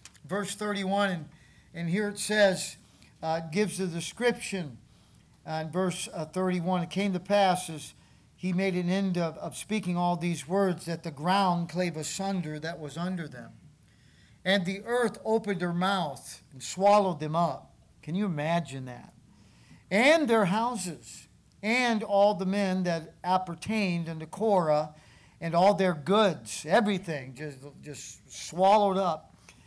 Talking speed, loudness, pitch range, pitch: 150 wpm, -28 LUFS, 160-200 Hz, 180 Hz